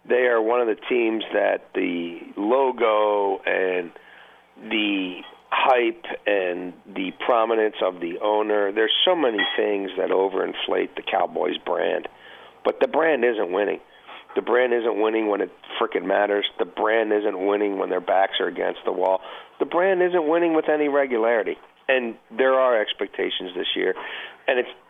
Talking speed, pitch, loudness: 160 wpm, 130 Hz, -22 LUFS